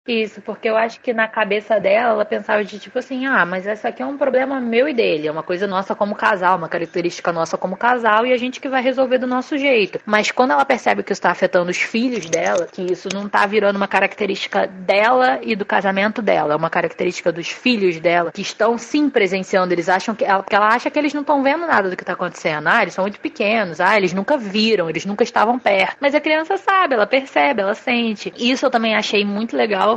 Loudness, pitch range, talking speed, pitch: -18 LUFS, 190-255 Hz, 240 wpm, 215 Hz